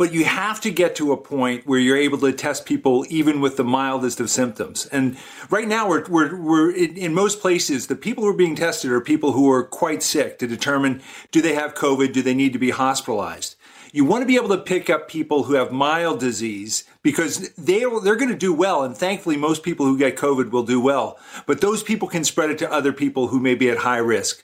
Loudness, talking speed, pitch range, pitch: -20 LUFS, 245 wpm, 130-175 Hz, 145 Hz